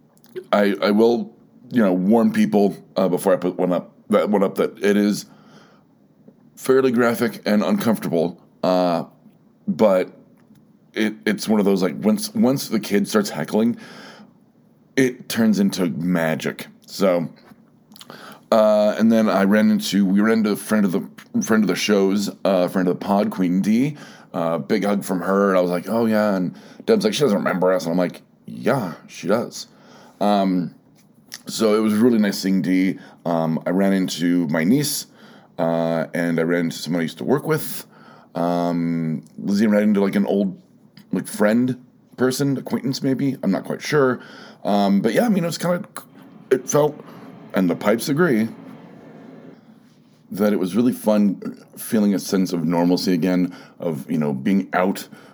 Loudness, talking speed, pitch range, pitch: -20 LUFS, 175 wpm, 95-140 Hz, 105 Hz